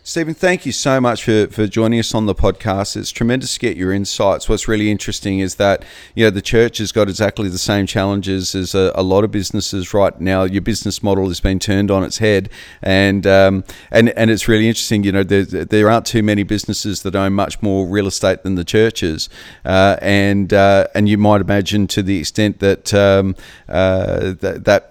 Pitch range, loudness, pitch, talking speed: 95-110 Hz, -15 LUFS, 100 Hz, 215 wpm